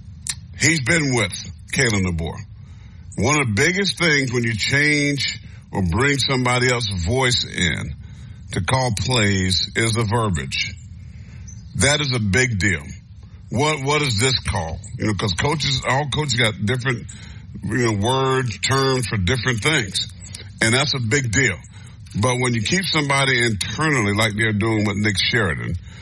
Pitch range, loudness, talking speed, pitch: 100-130 Hz, -19 LUFS, 155 wpm, 110 Hz